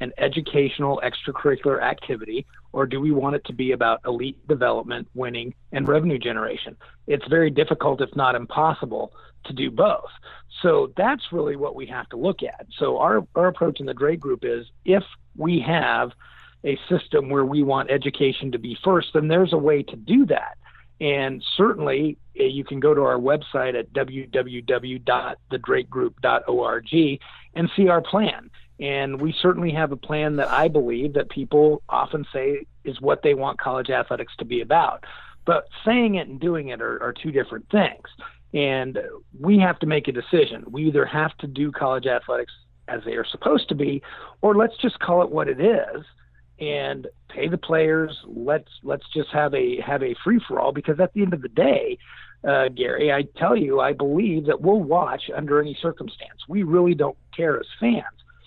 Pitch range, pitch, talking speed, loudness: 135-175 Hz, 150 Hz, 185 wpm, -22 LUFS